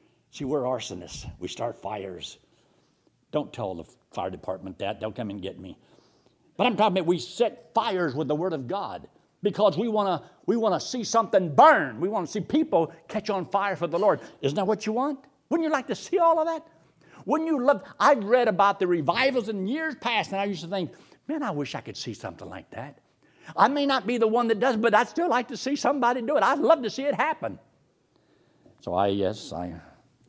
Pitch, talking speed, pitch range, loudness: 210 Hz, 225 wpm, 165-255 Hz, -25 LUFS